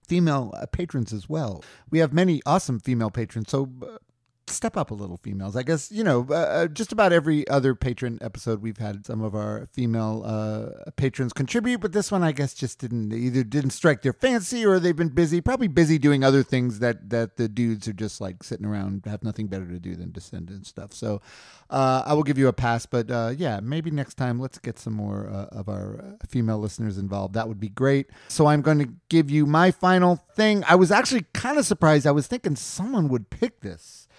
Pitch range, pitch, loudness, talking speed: 110-165 Hz, 130 Hz, -24 LUFS, 220 wpm